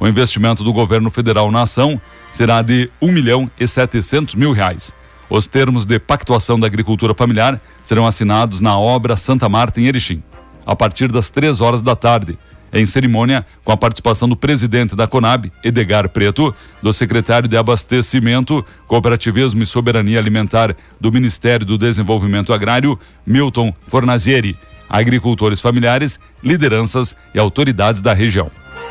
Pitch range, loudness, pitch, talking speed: 105-125 Hz, -14 LUFS, 115 Hz, 145 wpm